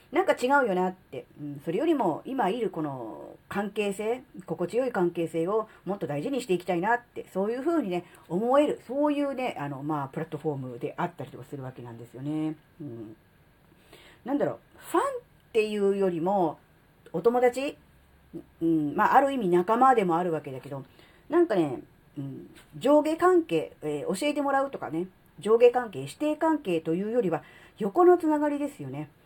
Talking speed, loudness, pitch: 365 characters per minute, -27 LUFS, 190 Hz